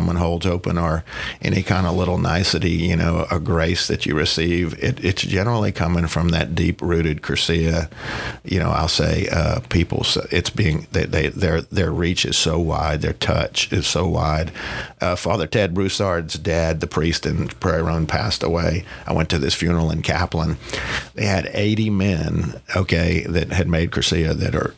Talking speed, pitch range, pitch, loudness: 185 wpm, 80-90 Hz, 85 Hz, -20 LUFS